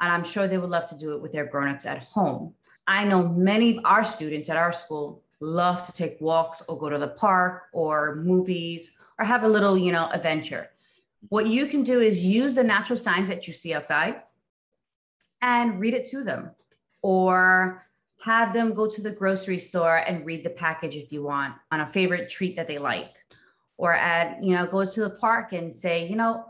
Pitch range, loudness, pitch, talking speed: 165-215 Hz, -24 LUFS, 180 Hz, 210 wpm